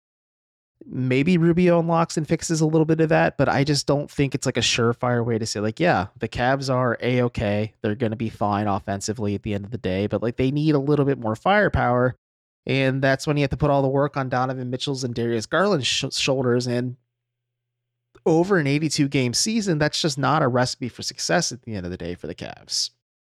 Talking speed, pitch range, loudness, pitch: 225 wpm, 115-145 Hz, -22 LUFS, 125 Hz